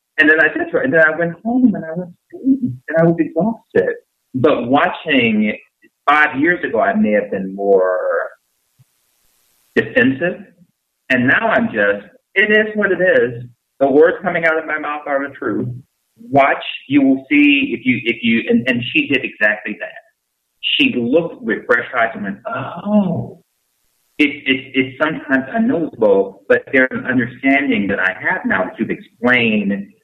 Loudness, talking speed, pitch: -16 LUFS, 170 wpm, 160 Hz